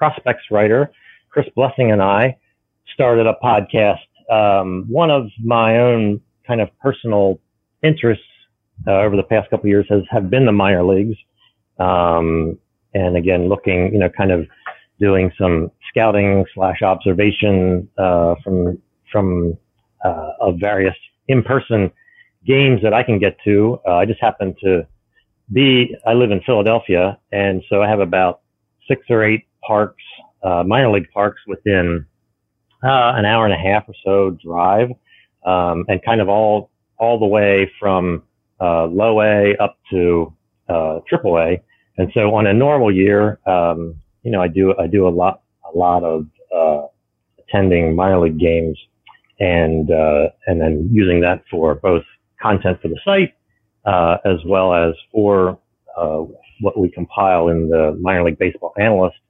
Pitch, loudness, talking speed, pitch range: 100 Hz, -16 LUFS, 160 wpm, 90-110 Hz